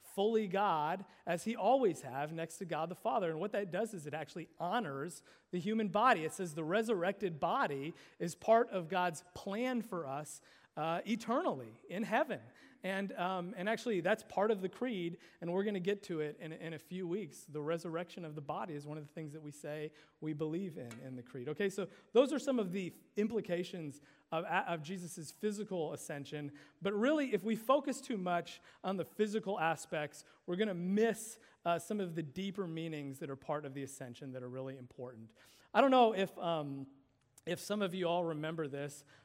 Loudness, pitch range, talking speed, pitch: -37 LUFS, 150-205 Hz, 205 wpm, 175 Hz